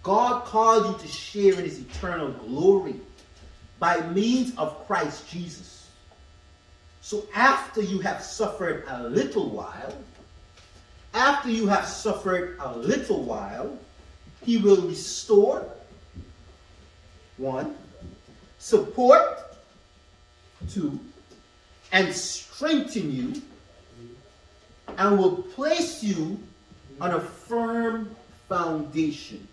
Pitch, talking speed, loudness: 185 Hz, 95 wpm, -25 LUFS